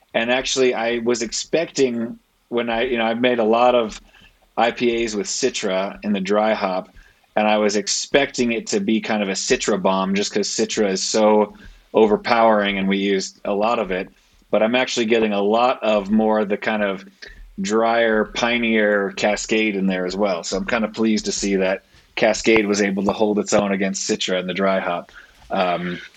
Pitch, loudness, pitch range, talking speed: 105 Hz, -20 LUFS, 100-115 Hz, 200 wpm